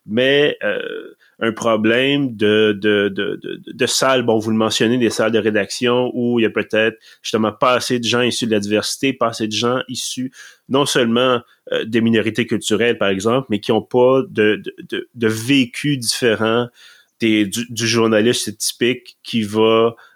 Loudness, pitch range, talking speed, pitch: -17 LUFS, 110-125 Hz, 185 wpm, 115 Hz